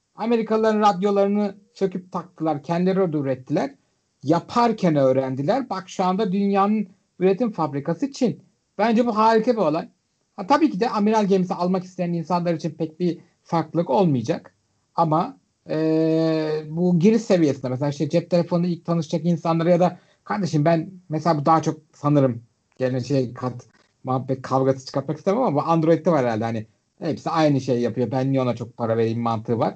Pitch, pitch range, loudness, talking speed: 165 Hz, 135-195 Hz, -22 LUFS, 165 wpm